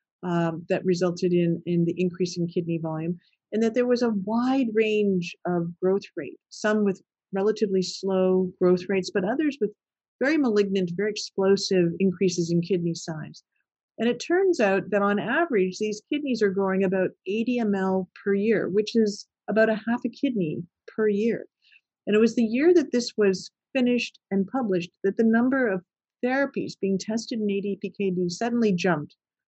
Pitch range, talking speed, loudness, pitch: 185-225 Hz, 170 wpm, -25 LUFS, 200 Hz